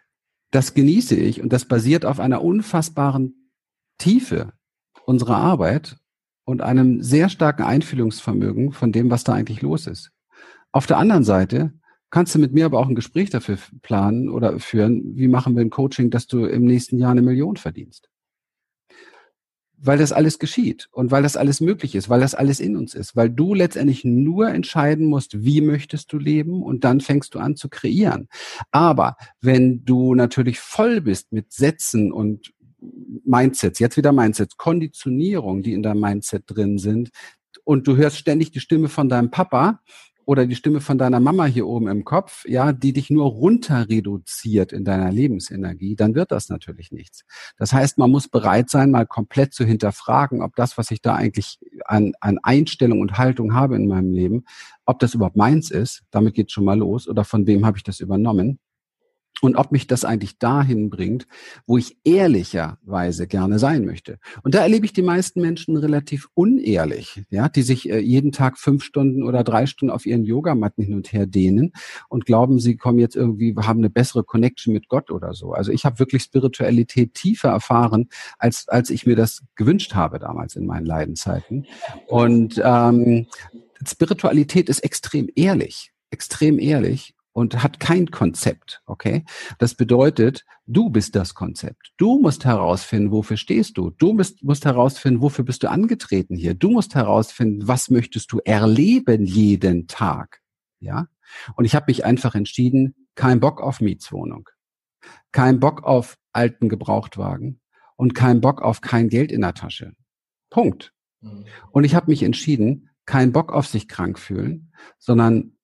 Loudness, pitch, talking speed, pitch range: -19 LUFS, 125 Hz, 175 wpm, 110-145 Hz